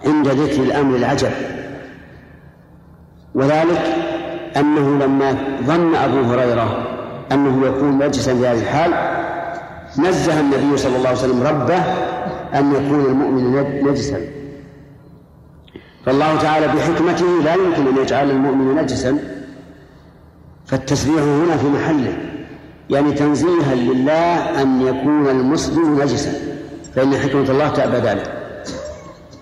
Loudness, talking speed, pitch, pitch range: -17 LUFS, 105 wpm, 140 Hz, 135-155 Hz